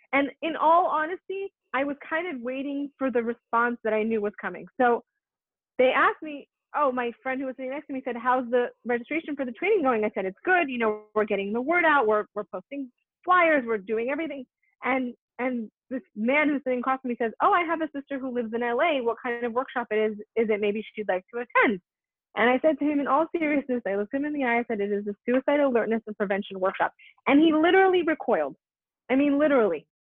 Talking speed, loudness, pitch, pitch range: 235 wpm, -26 LUFS, 255 Hz, 225-290 Hz